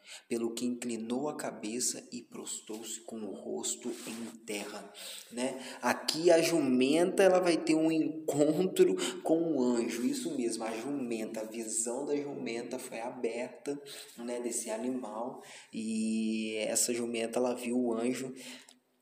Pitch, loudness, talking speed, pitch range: 125 Hz, -32 LUFS, 140 wpm, 115-150 Hz